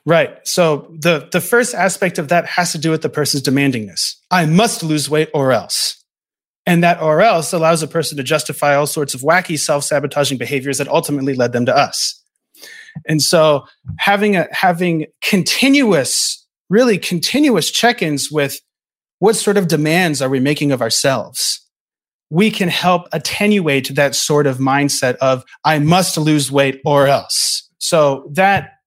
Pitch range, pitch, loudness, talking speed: 145-180 Hz, 155 Hz, -15 LUFS, 160 wpm